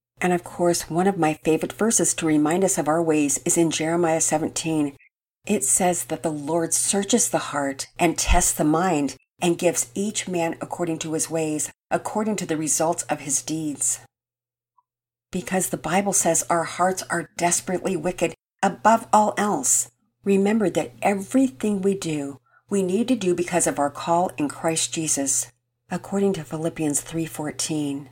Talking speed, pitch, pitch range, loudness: 165 wpm, 165 Hz, 150-180 Hz, -22 LUFS